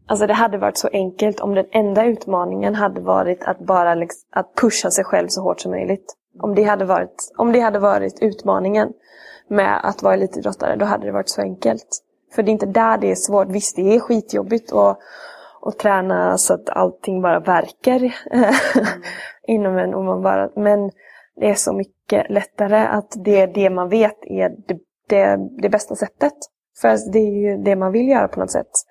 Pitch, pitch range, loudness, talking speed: 205 Hz, 180-215 Hz, -18 LUFS, 200 wpm